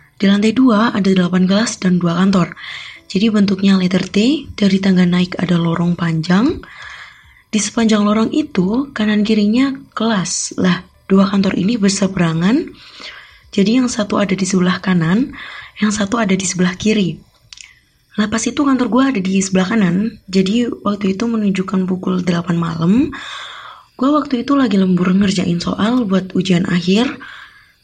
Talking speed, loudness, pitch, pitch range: 155 wpm, -15 LUFS, 200 Hz, 185-235 Hz